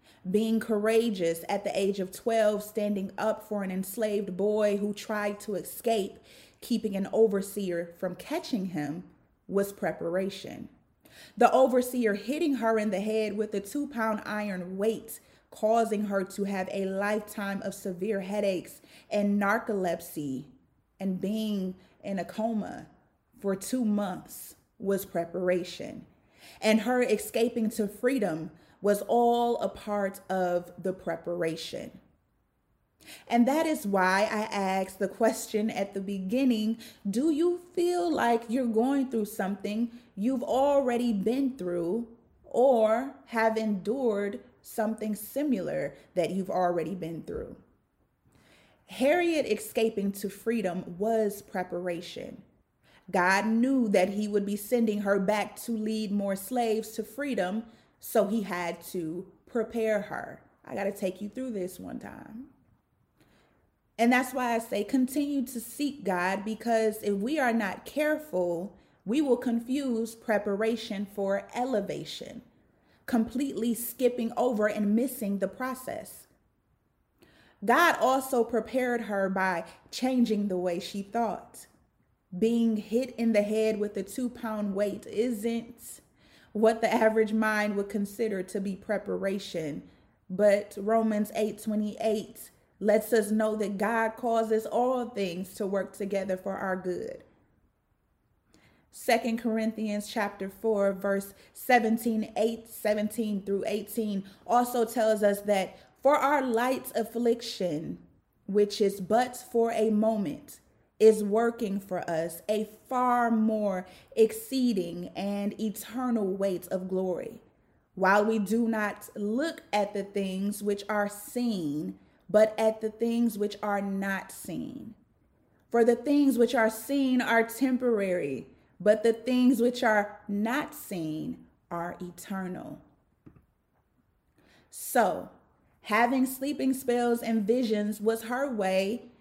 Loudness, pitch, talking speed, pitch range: -29 LUFS, 215 Hz, 130 wpm, 195-235 Hz